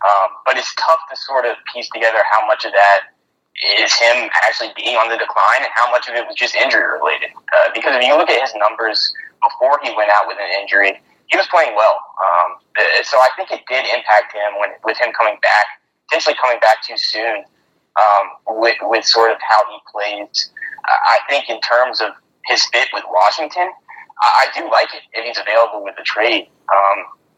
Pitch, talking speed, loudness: 160 Hz, 205 wpm, -15 LUFS